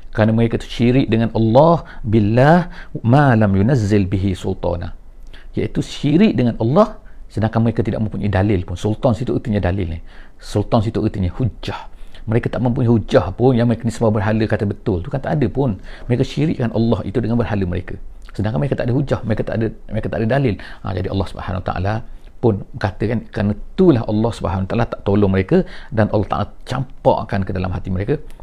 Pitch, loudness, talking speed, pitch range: 110 Hz, -18 LUFS, 190 wpm, 100-125 Hz